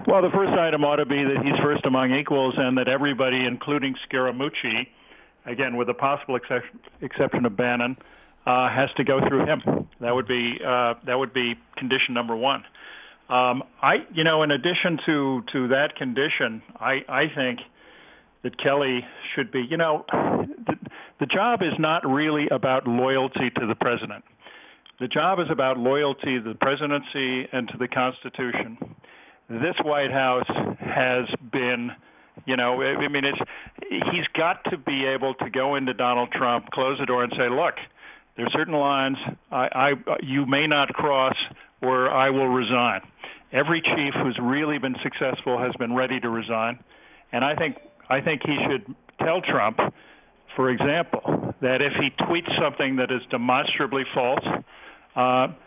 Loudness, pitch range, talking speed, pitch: -24 LUFS, 125-140 Hz, 165 wpm, 130 Hz